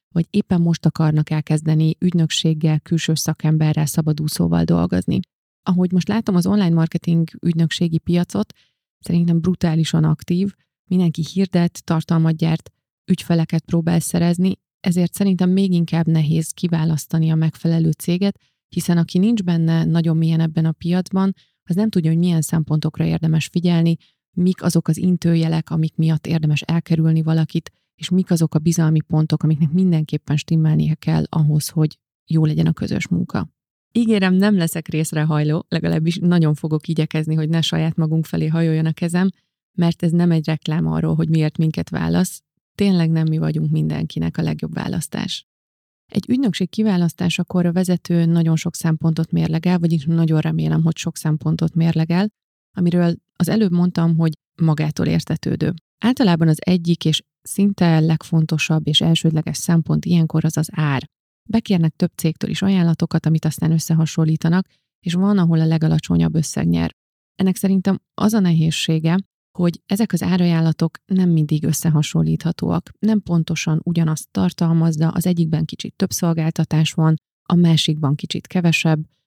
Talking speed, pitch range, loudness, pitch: 145 wpm, 160-175 Hz, -19 LUFS, 165 Hz